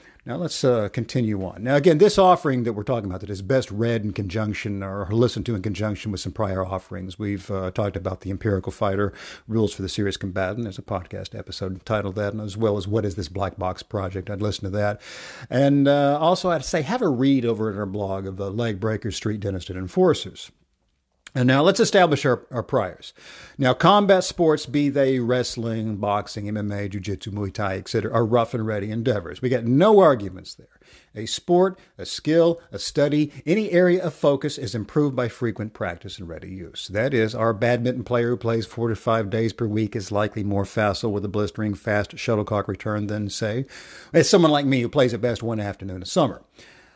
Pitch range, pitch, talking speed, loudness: 100-130 Hz, 110 Hz, 210 wpm, -23 LUFS